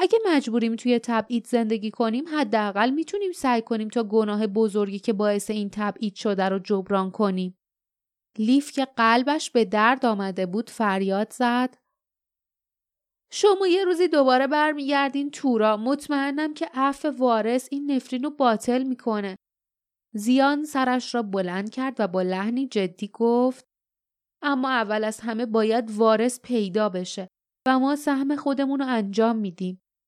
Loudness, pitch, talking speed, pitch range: -24 LUFS, 235 Hz, 140 wpm, 215-275 Hz